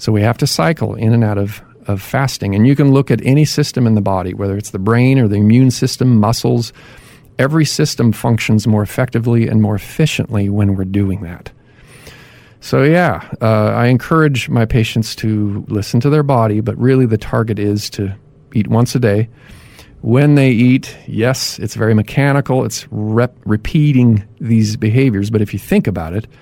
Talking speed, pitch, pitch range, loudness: 185 wpm, 115 Hz, 105-130 Hz, -14 LUFS